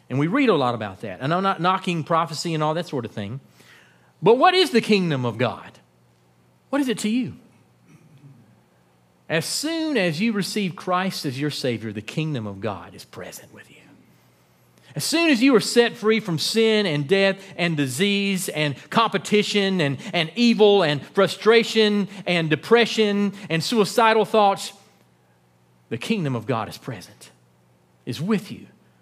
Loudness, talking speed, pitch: -21 LUFS, 170 wpm, 165 Hz